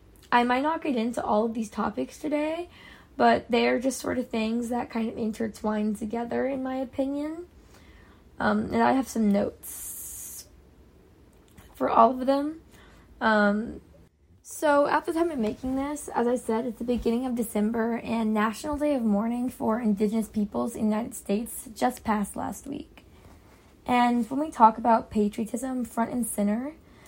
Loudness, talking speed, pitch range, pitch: -27 LUFS, 170 wpm, 220-260 Hz, 235 Hz